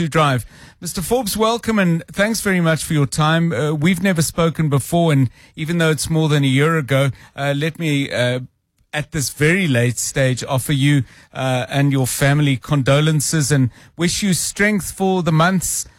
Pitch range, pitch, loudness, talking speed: 135-170 Hz, 150 Hz, -18 LUFS, 185 wpm